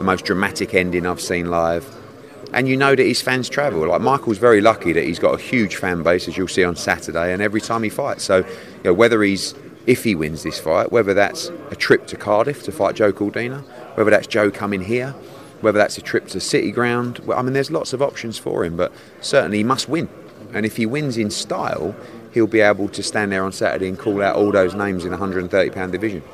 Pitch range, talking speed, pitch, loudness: 95-120 Hz, 240 wpm, 105 Hz, -19 LUFS